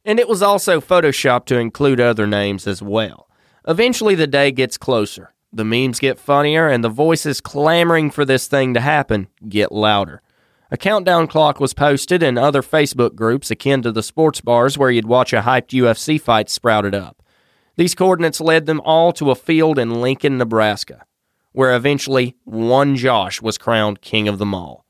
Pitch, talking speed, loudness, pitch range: 130 Hz, 180 wpm, -16 LUFS, 115-155 Hz